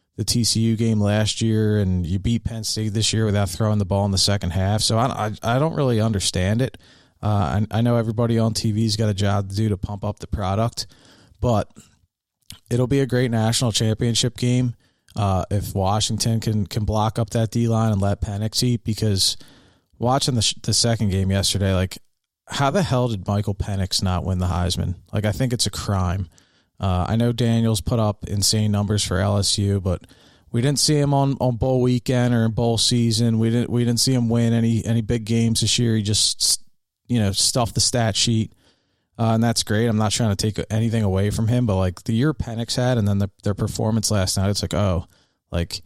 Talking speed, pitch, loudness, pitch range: 220 wpm, 110 Hz, -21 LUFS, 100-115 Hz